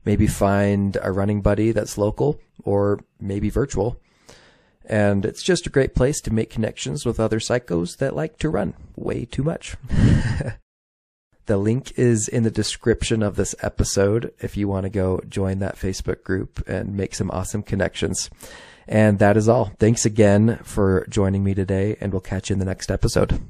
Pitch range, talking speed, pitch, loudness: 95-110 Hz, 180 wpm, 105 Hz, -22 LUFS